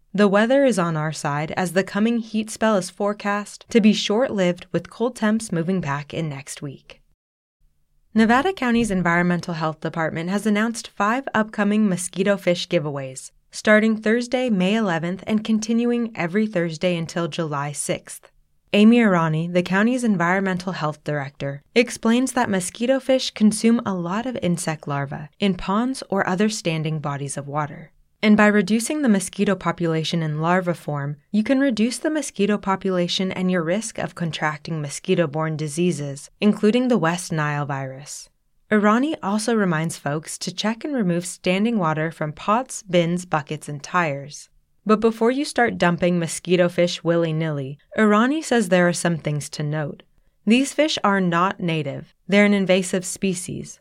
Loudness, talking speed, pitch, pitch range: -21 LUFS, 160 wpm, 185 Hz, 160-215 Hz